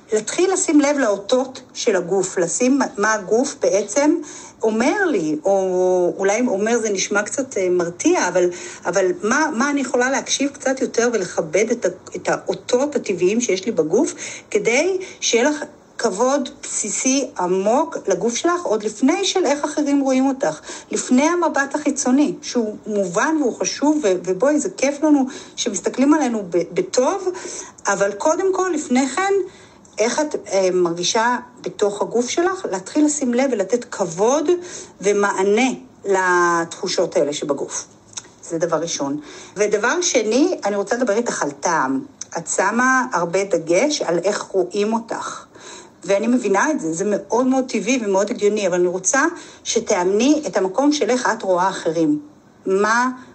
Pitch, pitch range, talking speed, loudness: 240 Hz, 195-290 Hz, 140 wpm, -19 LUFS